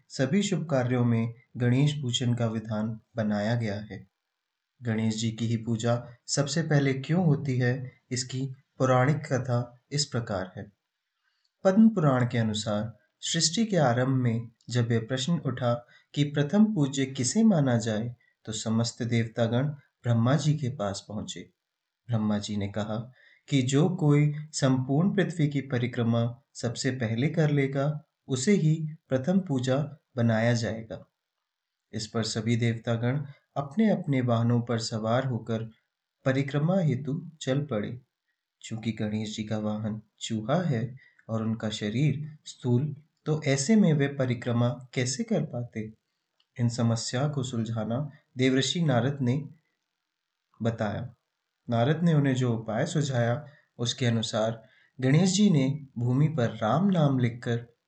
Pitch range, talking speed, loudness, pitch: 115-145 Hz, 135 wpm, -28 LUFS, 125 Hz